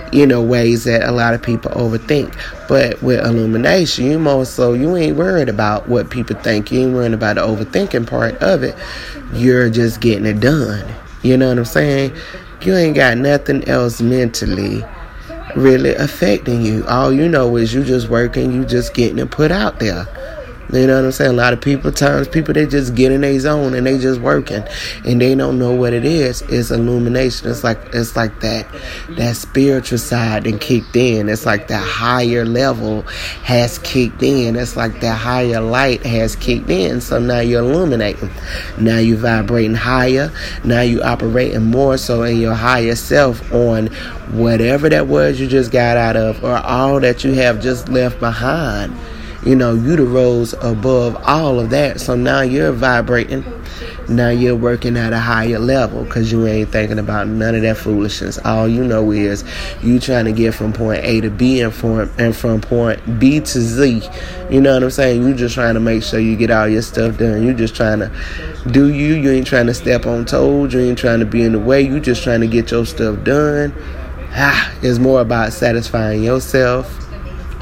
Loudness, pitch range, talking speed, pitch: -14 LUFS, 115-130 Hz, 200 wpm, 120 Hz